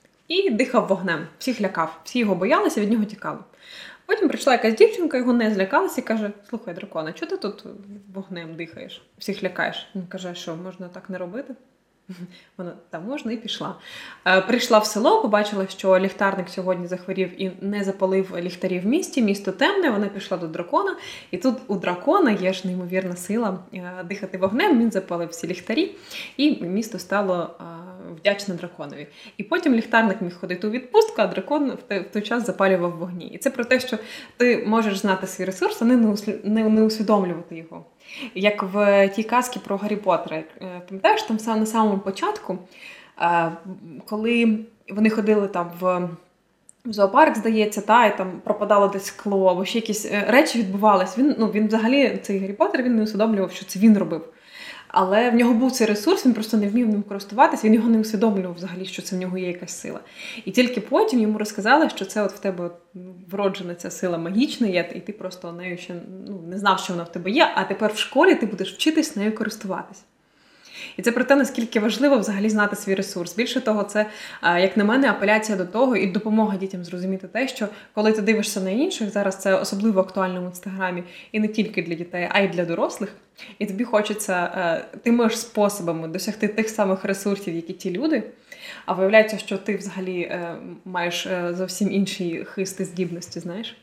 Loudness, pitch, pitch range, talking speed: -22 LUFS, 205 Hz, 185-225 Hz, 180 wpm